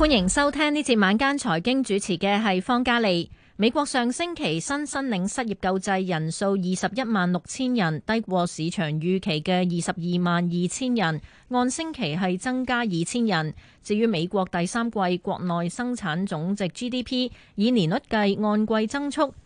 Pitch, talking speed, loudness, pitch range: 205 Hz, 260 characters per minute, -24 LUFS, 180-245 Hz